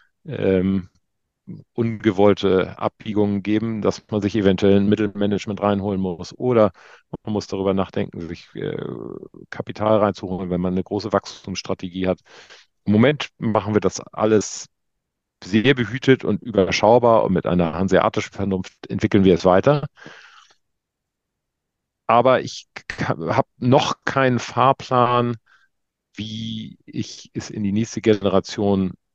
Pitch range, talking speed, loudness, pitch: 95-110 Hz, 120 wpm, -20 LUFS, 100 Hz